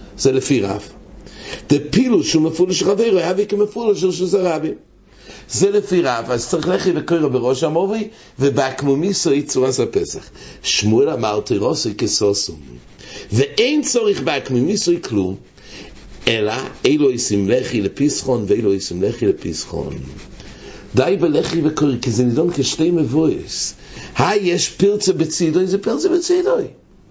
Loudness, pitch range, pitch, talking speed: -17 LUFS, 125-195 Hz, 155 Hz, 125 wpm